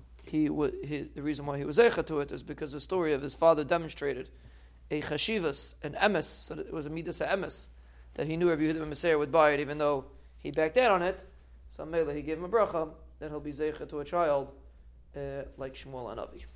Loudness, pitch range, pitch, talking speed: -31 LUFS, 135-160 Hz, 150 Hz, 240 wpm